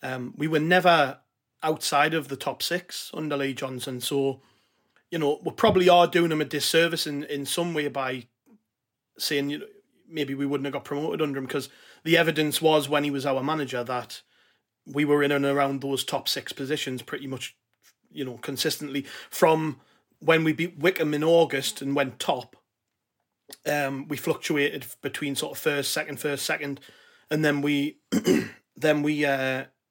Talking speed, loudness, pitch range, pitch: 175 wpm, -25 LUFS, 135-155 Hz, 145 Hz